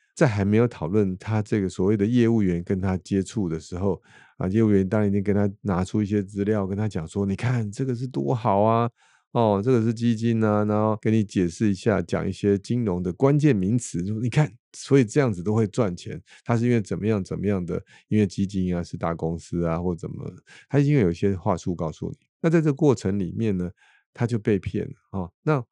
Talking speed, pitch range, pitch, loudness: 320 characters per minute, 95-120 Hz, 105 Hz, -24 LUFS